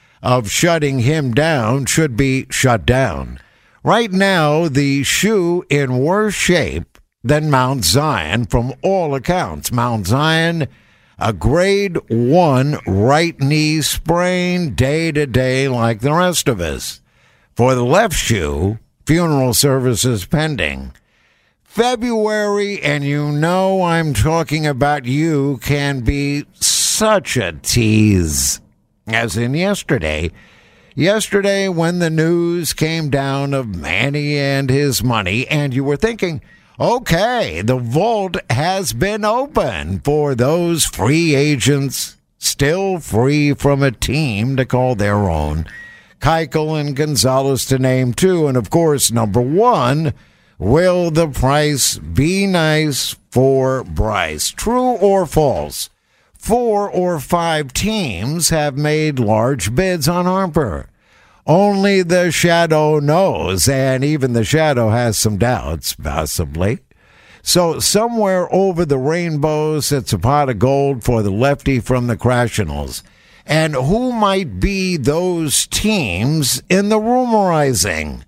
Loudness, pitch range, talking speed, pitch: -16 LUFS, 120-170 Hz, 125 wpm, 145 Hz